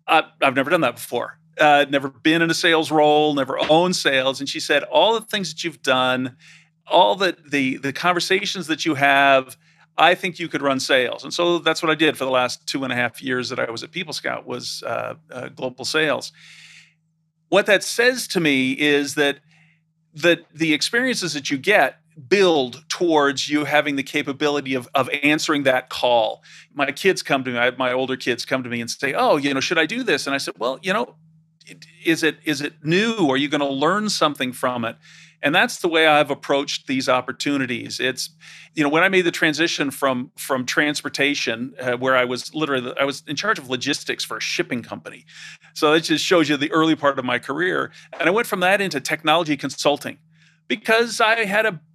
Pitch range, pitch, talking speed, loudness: 135-165 Hz, 150 Hz, 215 wpm, -20 LUFS